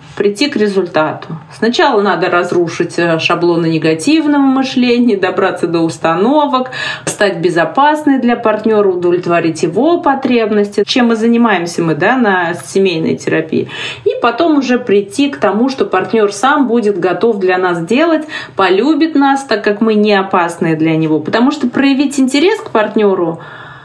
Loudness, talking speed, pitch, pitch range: -12 LUFS, 140 wpm, 210 Hz, 175-260 Hz